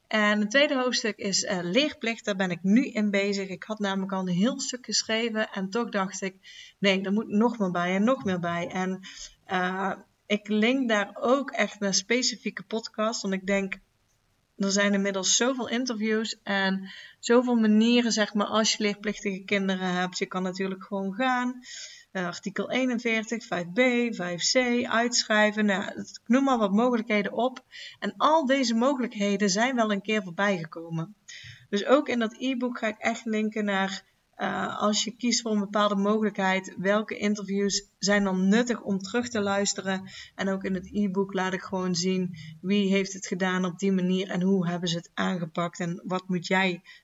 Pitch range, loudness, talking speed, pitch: 190-225 Hz, -26 LUFS, 185 wpm, 205 Hz